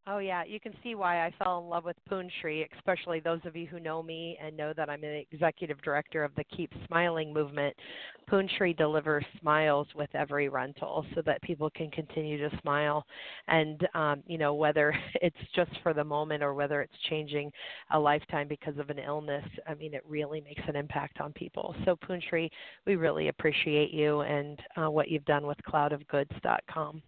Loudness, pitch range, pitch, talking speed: -32 LUFS, 145-170 Hz, 155 Hz, 190 wpm